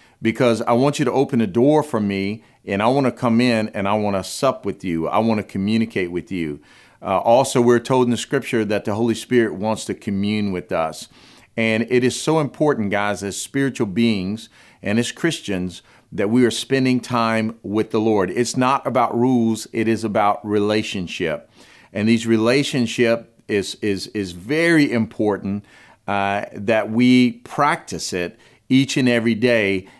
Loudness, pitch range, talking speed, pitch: -20 LUFS, 105-125 Hz, 180 wpm, 115 Hz